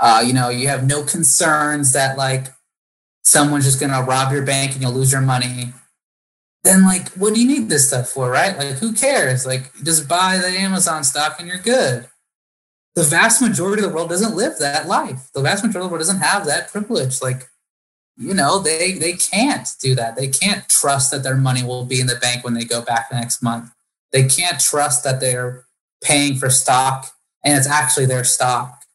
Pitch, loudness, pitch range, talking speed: 140 Hz, -16 LUFS, 130-175 Hz, 210 wpm